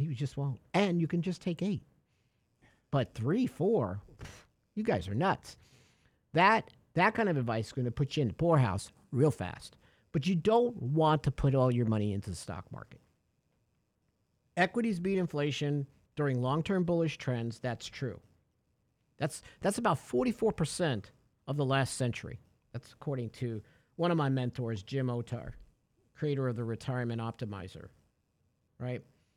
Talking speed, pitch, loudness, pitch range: 155 wpm, 130 Hz, -32 LUFS, 115-160 Hz